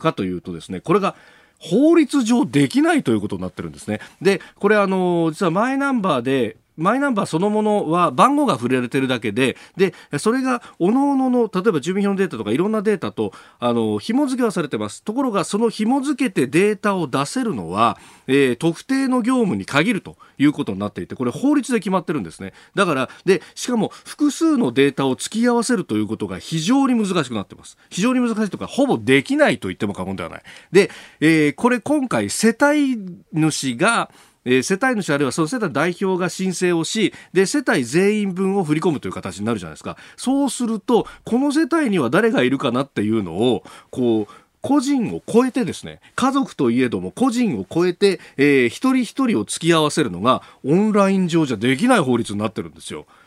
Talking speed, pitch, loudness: 415 characters per minute, 190 Hz, -19 LUFS